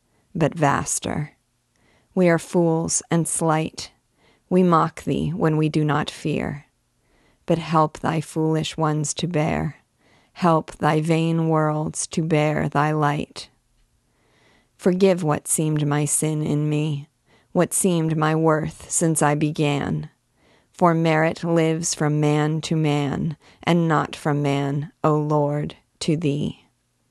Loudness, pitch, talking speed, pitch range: -22 LUFS, 155 Hz, 130 wpm, 150-165 Hz